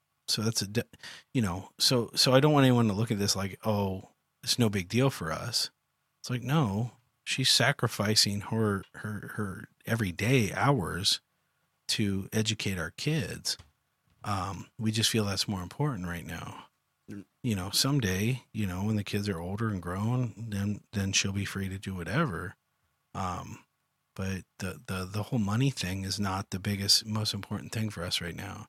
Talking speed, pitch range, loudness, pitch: 180 wpm, 95-120 Hz, -29 LUFS, 105 Hz